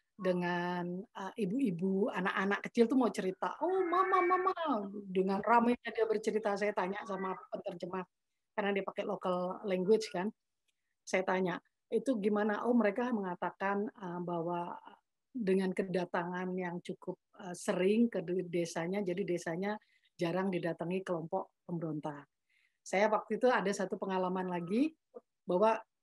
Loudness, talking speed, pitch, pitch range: -34 LUFS, 130 wpm, 195 Hz, 180-220 Hz